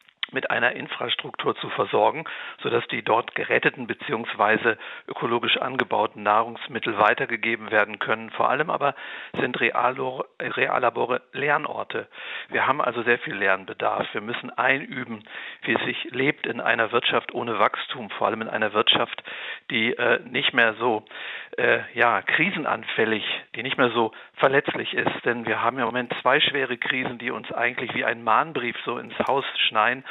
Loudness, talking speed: -24 LUFS, 155 wpm